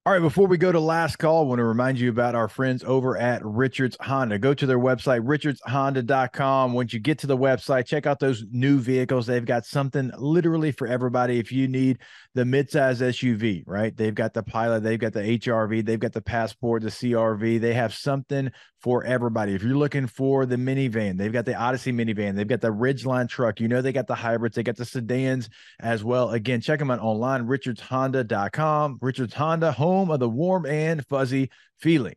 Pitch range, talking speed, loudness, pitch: 115-135 Hz, 210 wpm, -24 LUFS, 125 Hz